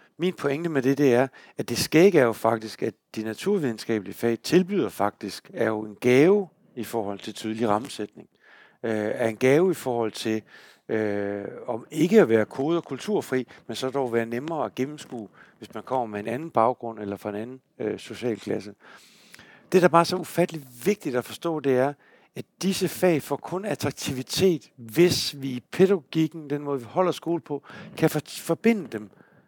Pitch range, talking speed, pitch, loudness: 110-165 Hz, 195 wpm, 130 Hz, -25 LUFS